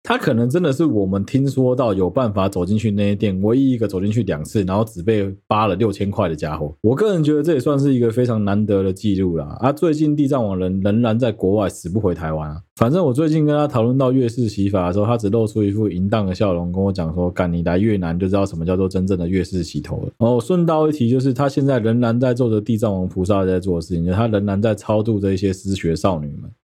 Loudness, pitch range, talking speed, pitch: -19 LUFS, 95-120 Hz, 385 characters per minute, 105 Hz